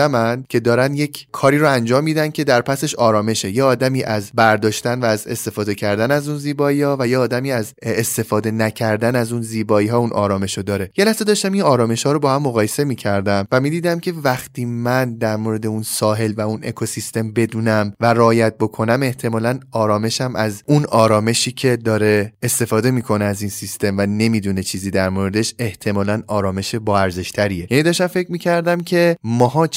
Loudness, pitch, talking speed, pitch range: -18 LUFS, 115 Hz, 185 wpm, 105-130 Hz